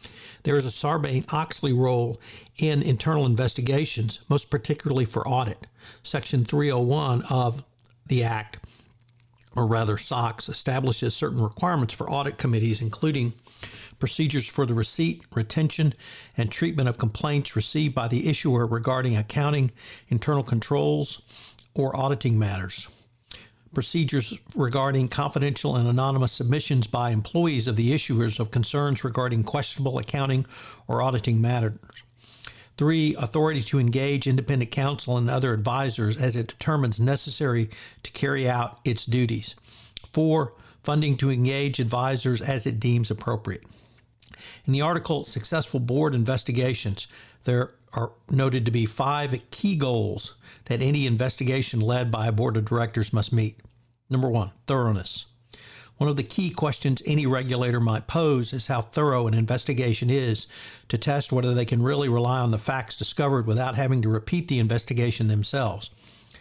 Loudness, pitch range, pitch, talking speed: -25 LUFS, 115-140 Hz, 125 Hz, 140 wpm